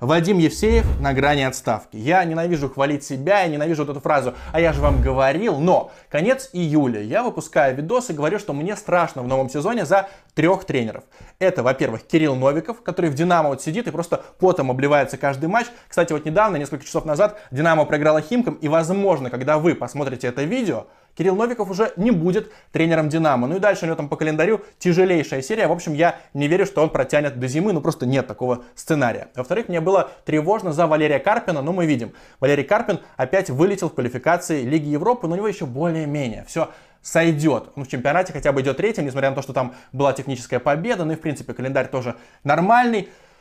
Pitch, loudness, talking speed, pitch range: 155 Hz, -20 LUFS, 205 wpm, 140-180 Hz